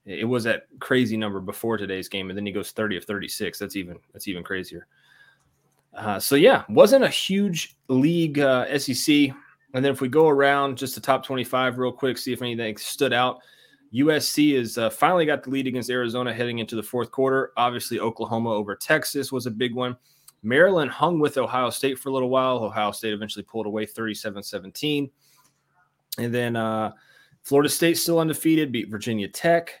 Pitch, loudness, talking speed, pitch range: 125 Hz, -23 LUFS, 185 wpm, 110-140 Hz